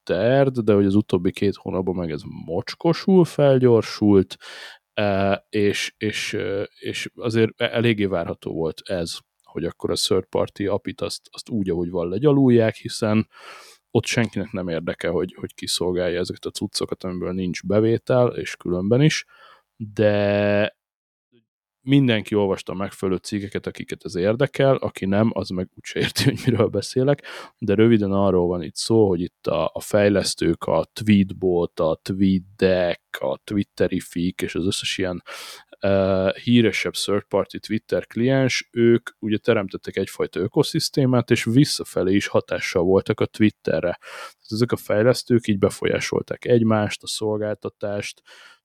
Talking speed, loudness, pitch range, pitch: 140 wpm, -22 LUFS, 95-120 Hz, 105 Hz